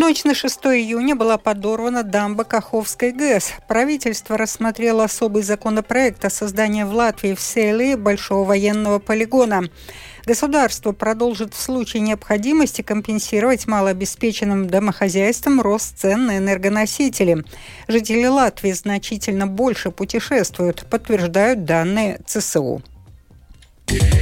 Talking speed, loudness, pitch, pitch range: 105 wpm, -18 LUFS, 220 Hz, 200-235 Hz